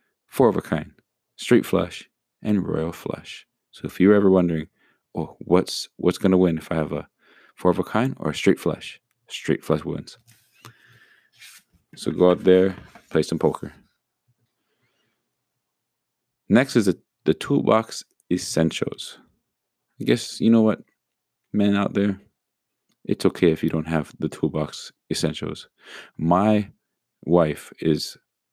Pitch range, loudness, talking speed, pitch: 80-100 Hz, -22 LUFS, 145 wpm, 95 Hz